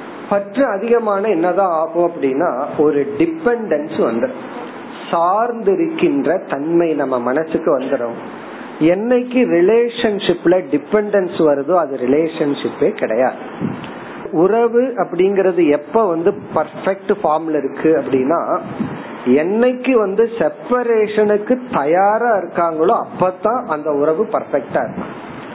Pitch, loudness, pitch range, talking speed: 190 Hz, -16 LUFS, 155-225 Hz, 65 wpm